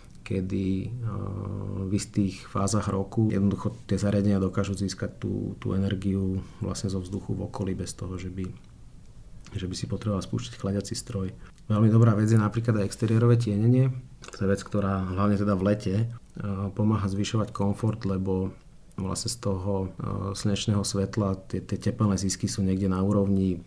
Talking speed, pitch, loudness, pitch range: 155 wpm, 100 Hz, -27 LUFS, 95-110 Hz